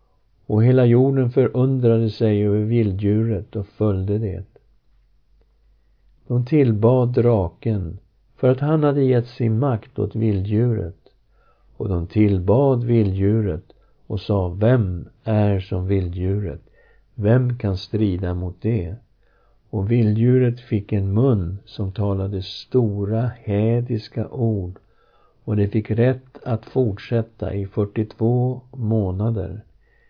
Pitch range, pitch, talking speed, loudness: 100-120 Hz, 110 Hz, 110 wpm, -21 LUFS